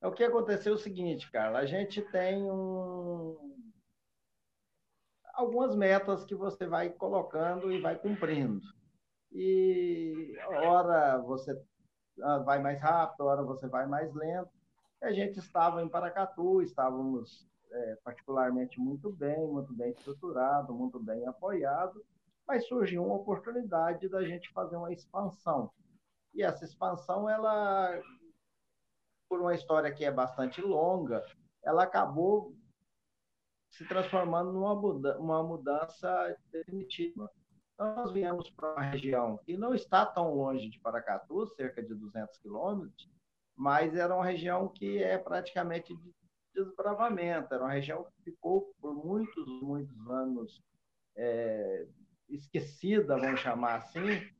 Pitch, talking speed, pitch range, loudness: 175 Hz, 125 wpm, 140-195 Hz, -33 LUFS